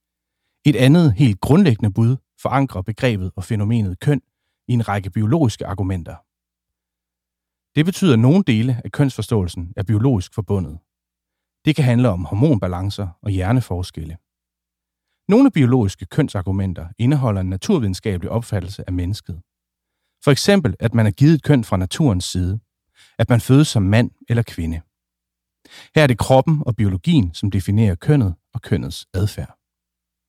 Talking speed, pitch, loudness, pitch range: 140 wpm, 100 Hz, -18 LUFS, 90-125 Hz